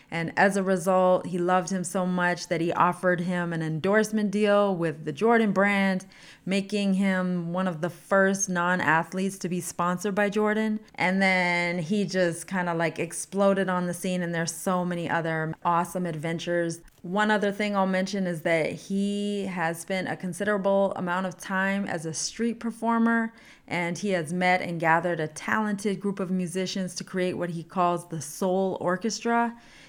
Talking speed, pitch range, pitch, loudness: 175 wpm, 175-195 Hz, 185 Hz, -26 LUFS